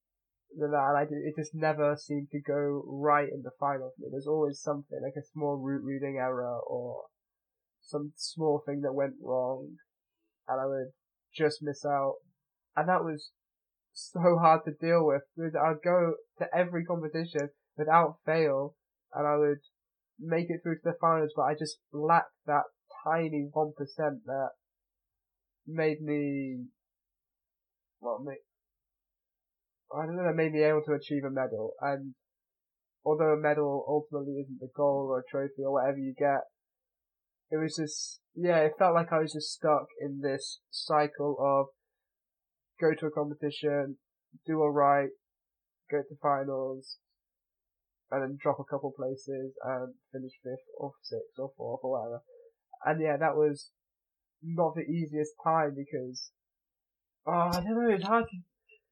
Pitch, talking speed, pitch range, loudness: 150 Hz, 160 wpm, 140-160 Hz, -31 LUFS